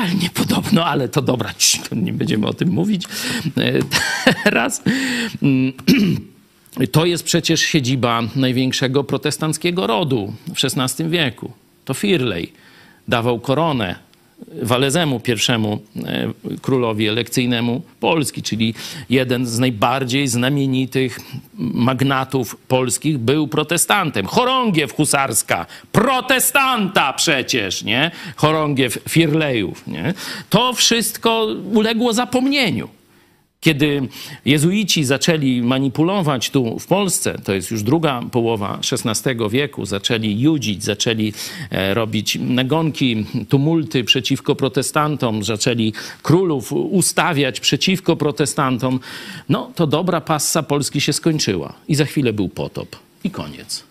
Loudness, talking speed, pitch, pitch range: -18 LUFS, 100 wpm, 140 Hz, 125-170 Hz